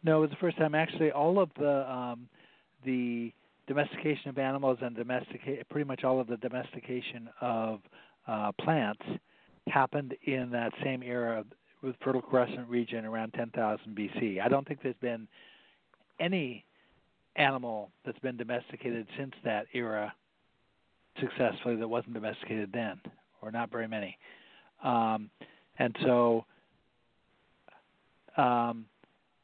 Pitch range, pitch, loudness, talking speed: 115-135 Hz, 125 Hz, -33 LUFS, 130 wpm